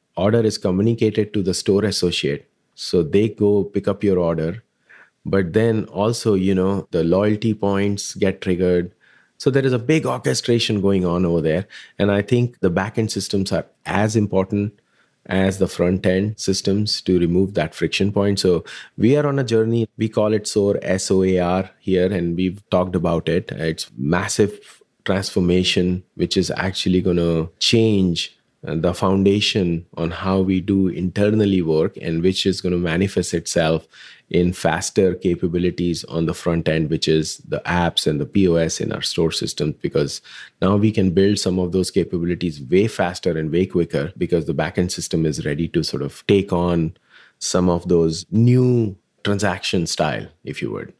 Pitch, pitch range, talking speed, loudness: 95 Hz, 90-105 Hz, 175 wpm, -20 LUFS